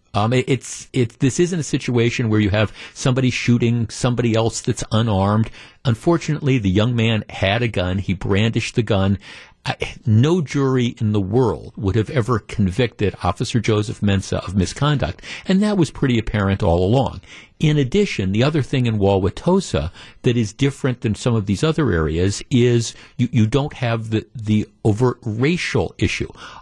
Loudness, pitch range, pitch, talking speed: -19 LUFS, 105-130 Hz, 115 Hz, 170 wpm